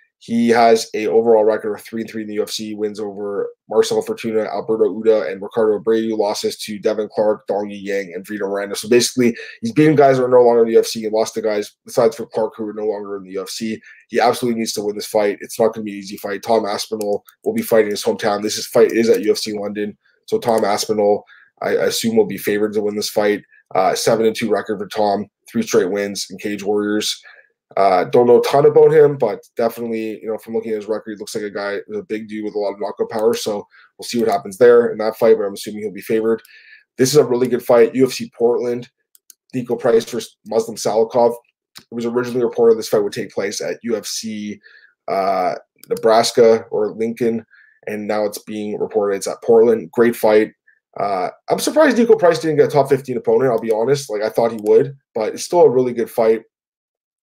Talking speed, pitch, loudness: 230 wpm, 115 Hz, -18 LUFS